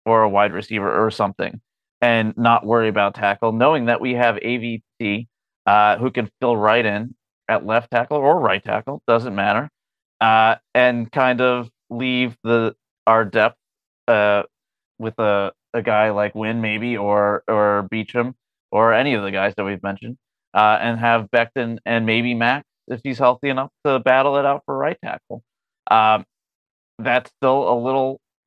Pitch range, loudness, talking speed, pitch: 105-125 Hz, -19 LUFS, 170 wpm, 115 Hz